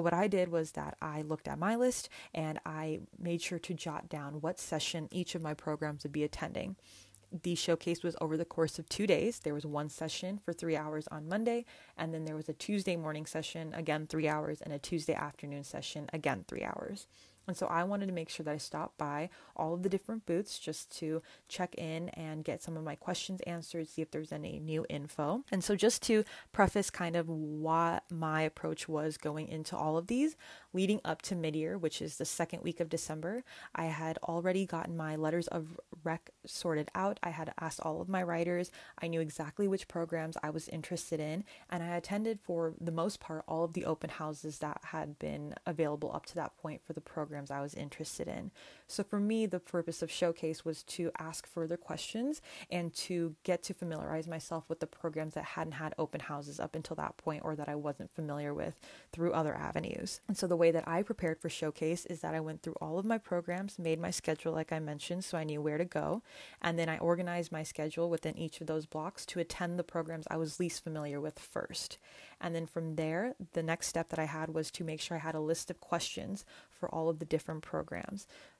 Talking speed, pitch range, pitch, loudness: 225 wpm, 155-175 Hz, 165 Hz, -37 LUFS